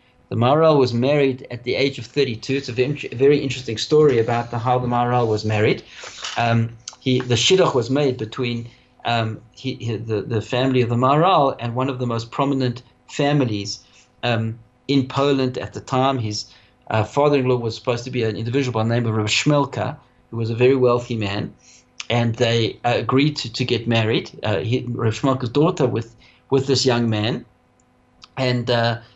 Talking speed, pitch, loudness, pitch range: 185 wpm, 125 Hz, -20 LUFS, 115-130 Hz